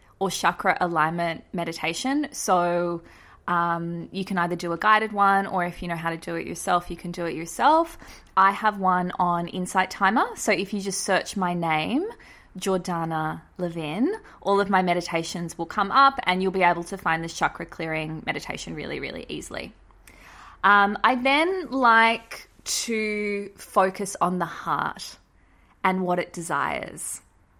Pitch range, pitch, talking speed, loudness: 170-200 Hz, 180 Hz, 165 wpm, -24 LUFS